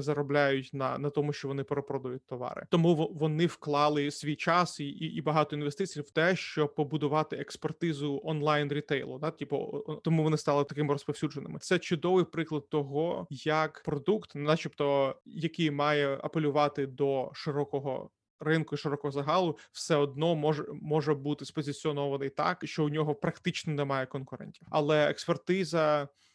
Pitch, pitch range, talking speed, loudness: 150 Hz, 145-160 Hz, 140 wpm, -31 LUFS